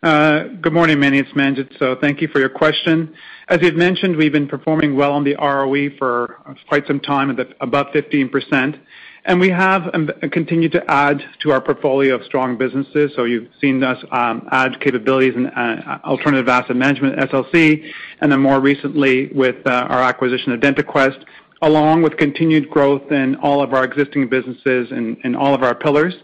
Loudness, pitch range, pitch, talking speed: -16 LUFS, 130-155 Hz, 140 Hz, 185 wpm